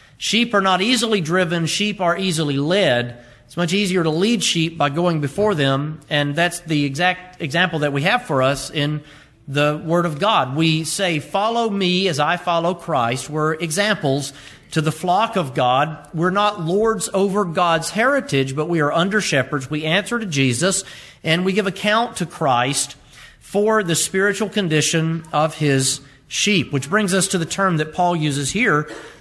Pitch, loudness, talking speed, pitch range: 165 Hz, -19 LUFS, 180 wpm, 145-195 Hz